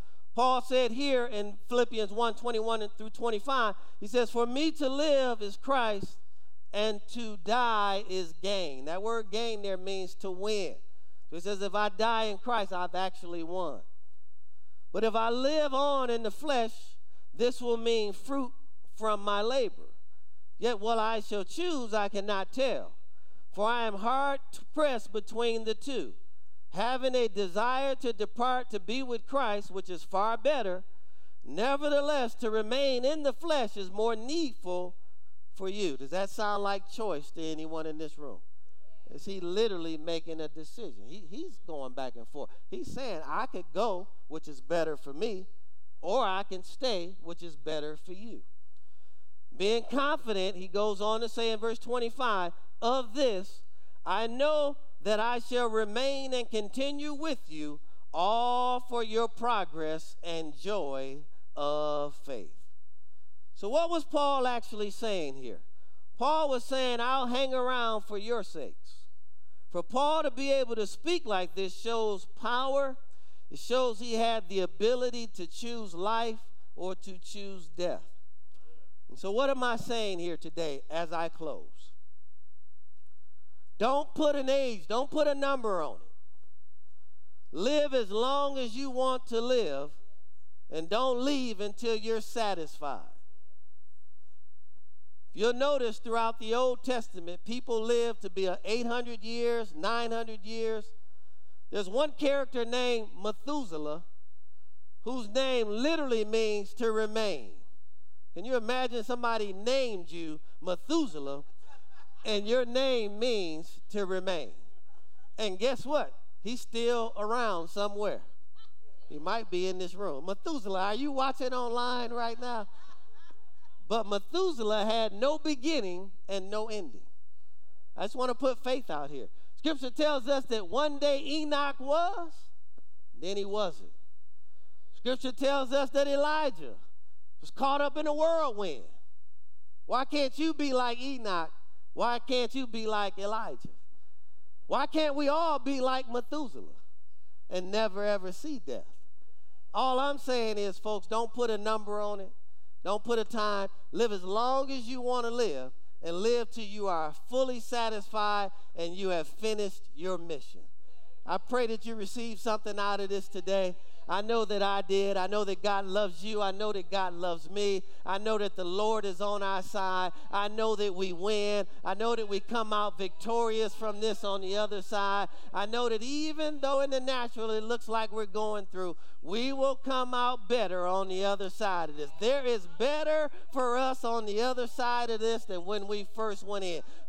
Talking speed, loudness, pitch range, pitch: 160 wpm, -32 LUFS, 180-245 Hz, 215 Hz